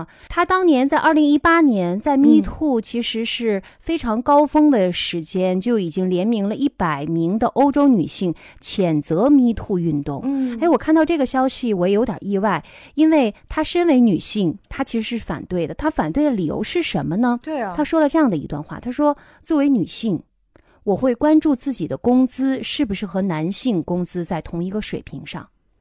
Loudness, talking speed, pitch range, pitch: -19 LUFS, 295 characters per minute, 185-290 Hz, 240 Hz